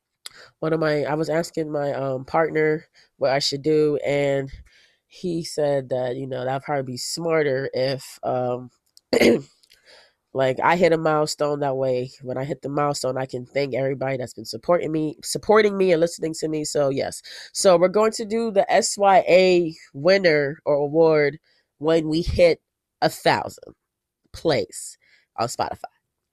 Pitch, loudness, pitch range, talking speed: 150 Hz, -22 LUFS, 135-165 Hz, 160 wpm